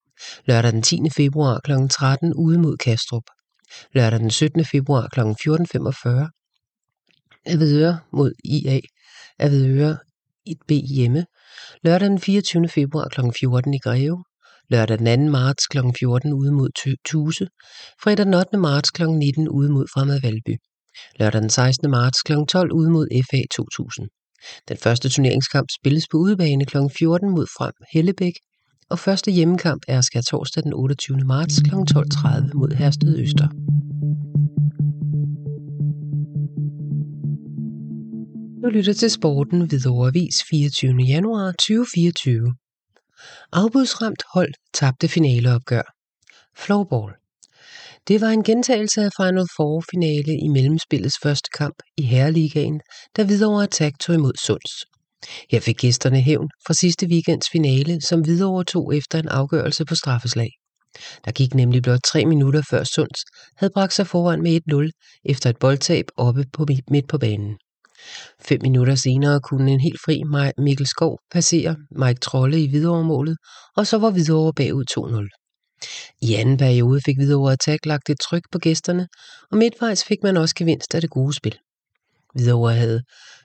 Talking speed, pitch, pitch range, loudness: 140 wpm, 150 Hz, 130-165 Hz, -19 LUFS